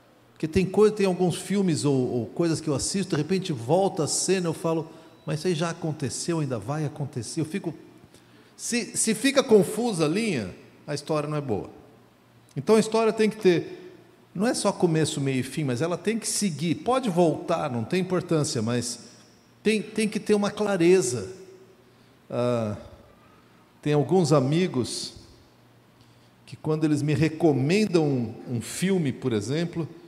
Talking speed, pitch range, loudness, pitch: 170 wpm, 140-190 Hz, -25 LUFS, 165 Hz